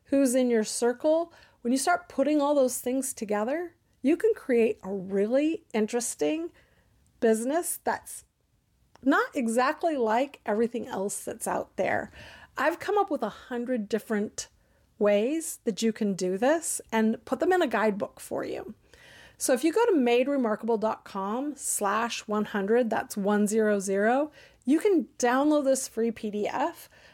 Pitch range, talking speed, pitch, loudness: 220-290 Hz, 145 wpm, 245 Hz, -27 LUFS